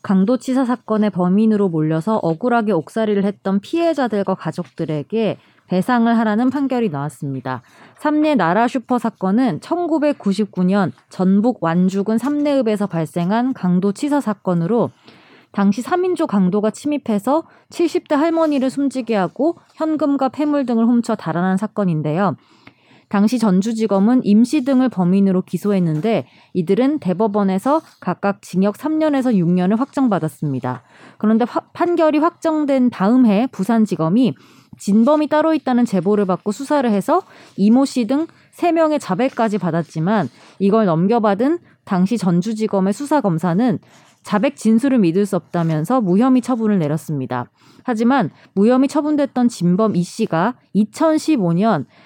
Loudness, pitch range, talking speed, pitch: -18 LUFS, 185-265 Hz, 310 characters per minute, 220 Hz